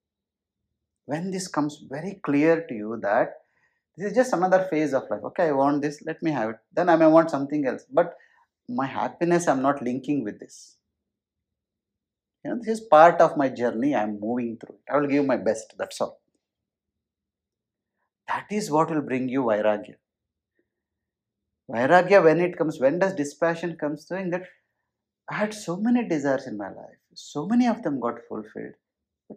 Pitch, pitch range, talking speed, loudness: 150 Hz, 125-175 Hz, 180 wpm, -24 LUFS